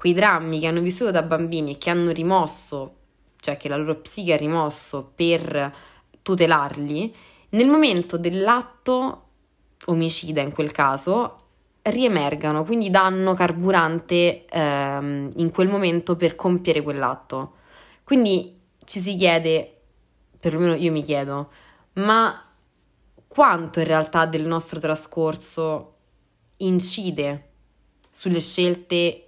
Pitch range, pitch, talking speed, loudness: 150-185 Hz, 165 Hz, 115 wpm, -21 LUFS